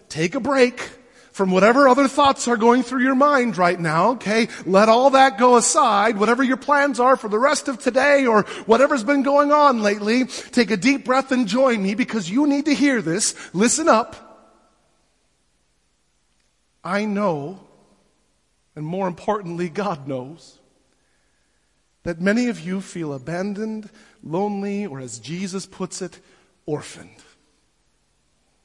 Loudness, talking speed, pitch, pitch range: -19 LUFS, 145 wpm, 220 Hz, 180-260 Hz